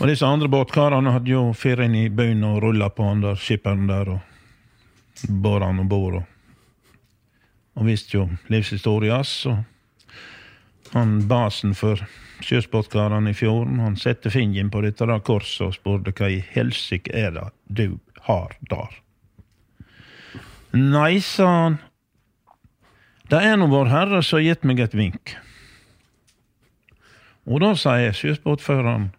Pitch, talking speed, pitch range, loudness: 110 Hz, 140 wpm, 100-125 Hz, -21 LUFS